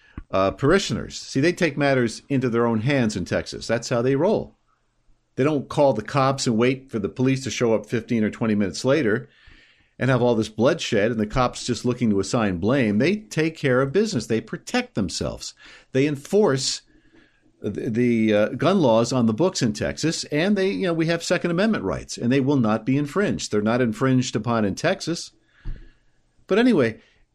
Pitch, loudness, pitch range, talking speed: 125 Hz, -22 LUFS, 110-145 Hz, 195 wpm